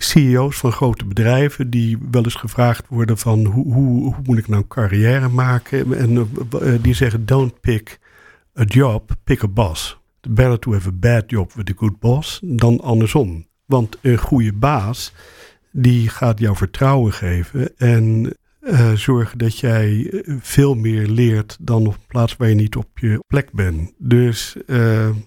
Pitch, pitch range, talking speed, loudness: 120 Hz, 110-130 Hz, 170 wpm, -17 LUFS